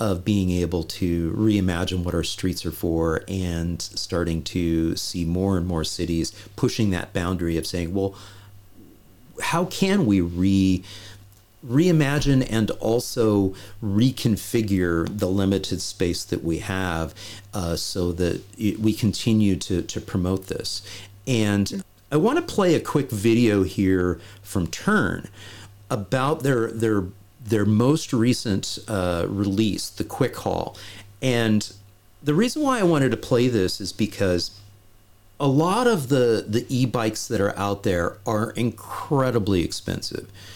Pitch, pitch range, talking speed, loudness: 100 Hz, 95-115 Hz, 140 wpm, -23 LUFS